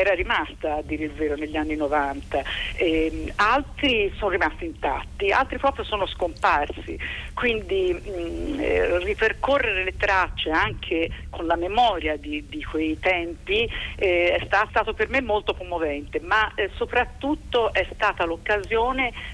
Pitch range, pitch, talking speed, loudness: 160-260 Hz, 200 Hz, 140 wpm, -24 LUFS